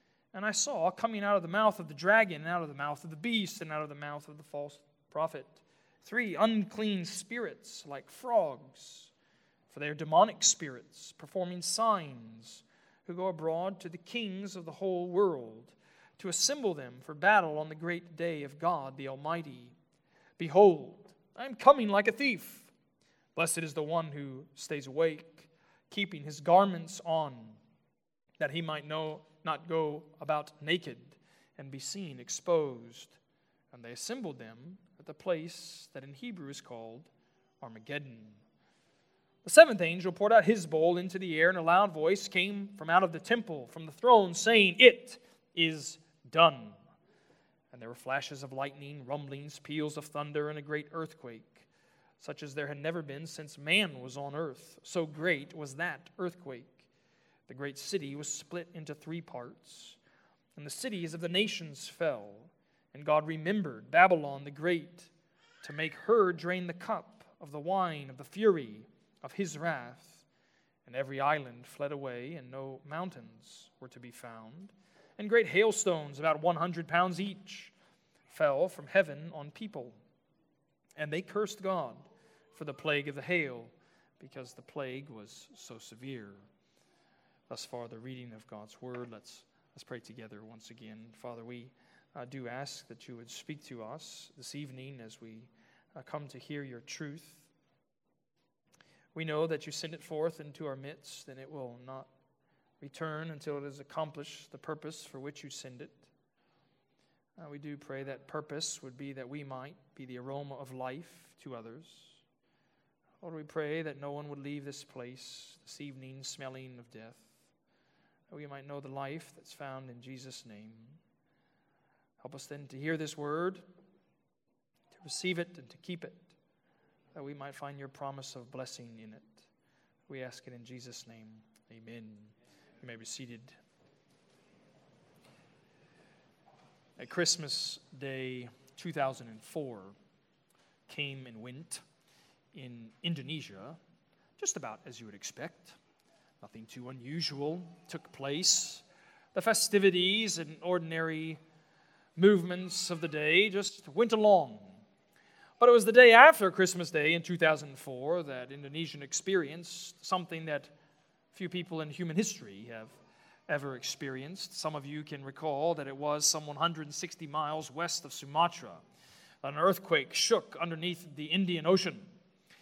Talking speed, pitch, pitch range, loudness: 160 wpm, 155 Hz, 135-175 Hz, -31 LUFS